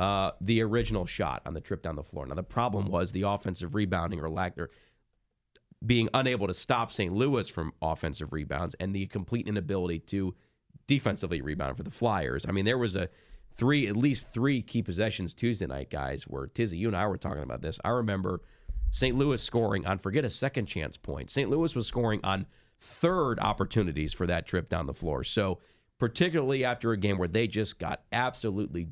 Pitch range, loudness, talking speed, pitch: 85-115 Hz, -30 LUFS, 200 wpm, 100 Hz